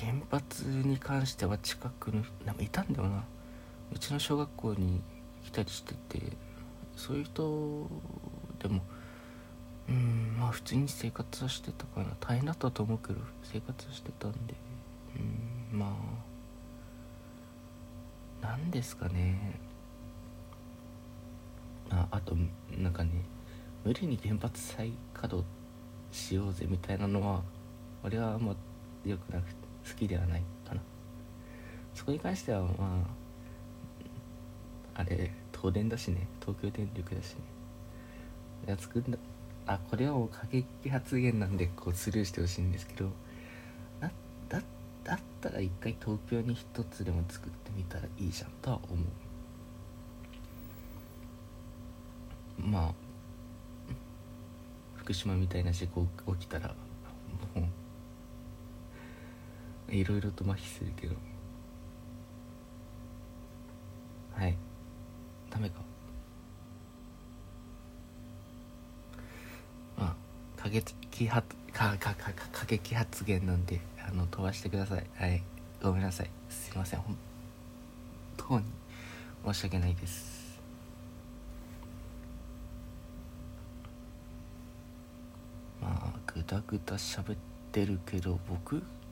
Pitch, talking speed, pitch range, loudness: 100 Hz, 200 characters per minute, 85-120 Hz, -37 LUFS